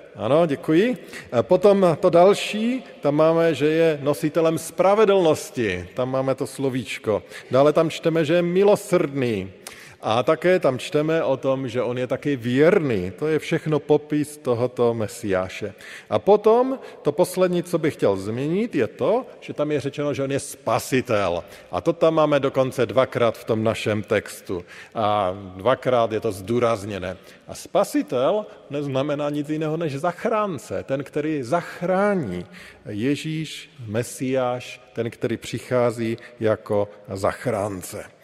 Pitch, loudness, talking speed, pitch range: 145 Hz, -22 LUFS, 140 wpm, 120-165 Hz